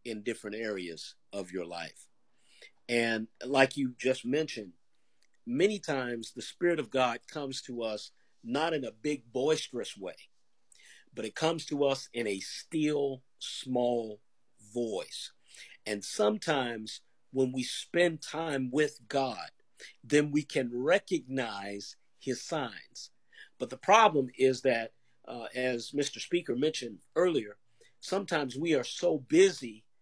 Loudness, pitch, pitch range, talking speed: -32 LUFS, 130 Hz, 115-150 Hz, 130 wpm